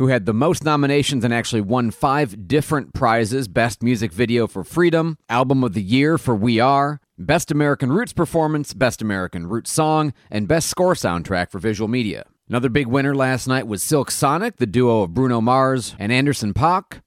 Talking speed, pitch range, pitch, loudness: 190 wpm, 115-145 Hz, 125 Hz, -19 LUFS